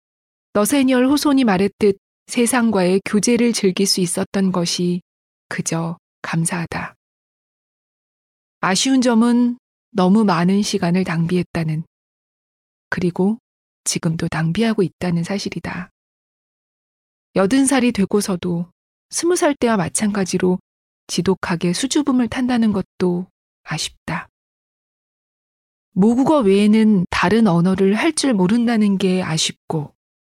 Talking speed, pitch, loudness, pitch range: 235 characters per minute, 195 Hz, -18 LUFS, 180-230 Hz